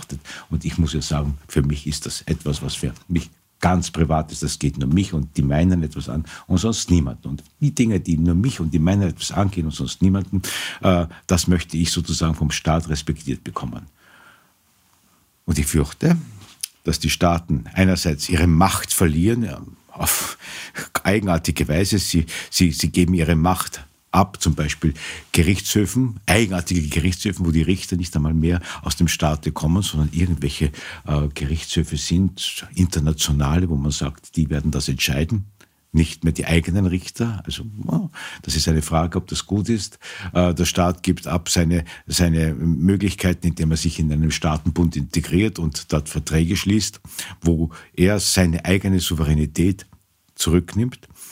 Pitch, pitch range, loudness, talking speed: 85 Hz, 80-90 Hz, -21 LUFS, 160 wpm